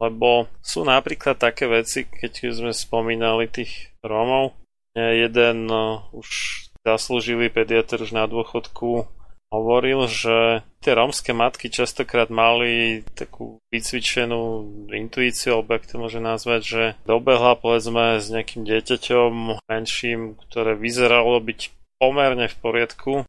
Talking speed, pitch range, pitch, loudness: 115 wpm, 110-120 Hz, 115 Hz, -21 LUFS